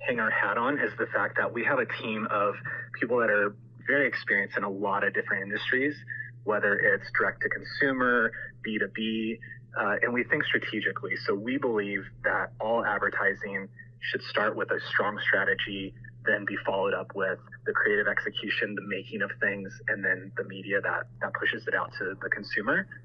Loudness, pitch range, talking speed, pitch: -28 LUFS, 105-125 Hz, 185 wpm, 120 Hz